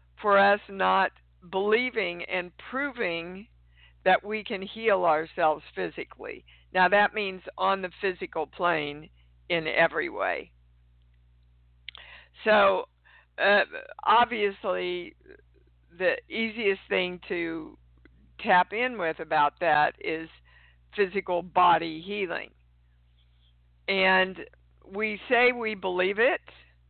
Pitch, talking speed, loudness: 175 Hz, 100 wpm, -26 LUFS